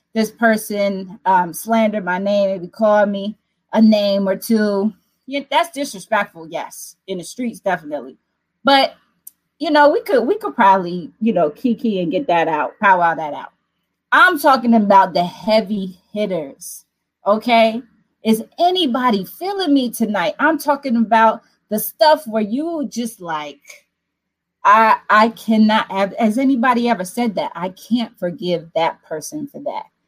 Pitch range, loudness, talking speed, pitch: 190-260 Hz, -17 LUFS, 150 wpm, 220 Hz